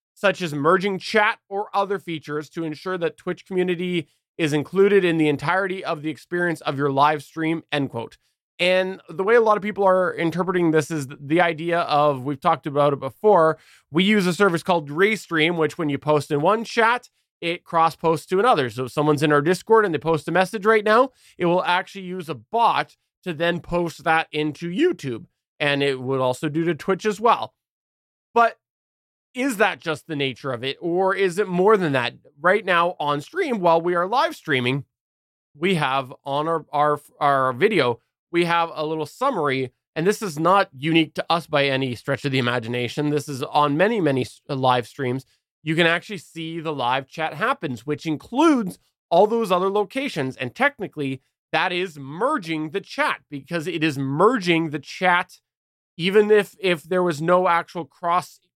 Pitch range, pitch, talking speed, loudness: 145-185 Hz, 165 Hz, 190 wpm, -22 LUFS